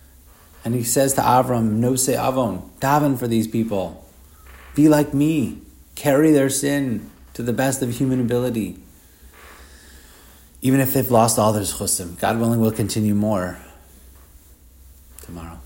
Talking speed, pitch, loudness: 140 wpm, 105 Hz, -20 LUFS